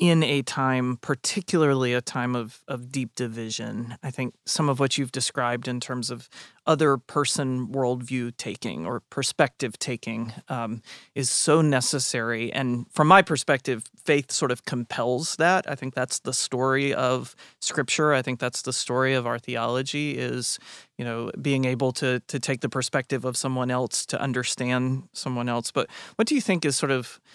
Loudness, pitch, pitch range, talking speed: -25 LUFS, 130 Hz, 125-140 Hz, 175 wpm